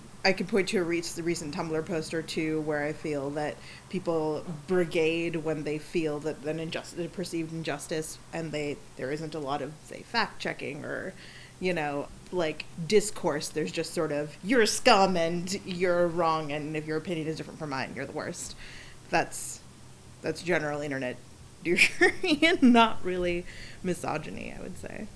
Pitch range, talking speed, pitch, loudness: 150-180 Hz, 180 wpm, 165 Hz, -29 LUFS